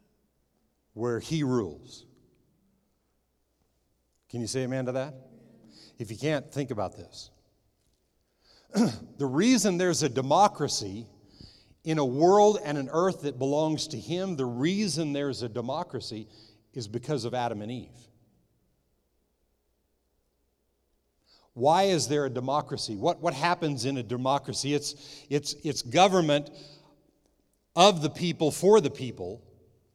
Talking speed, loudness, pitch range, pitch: 125 wpm, -27 LUFS, 105-150 Hz, 130 Hz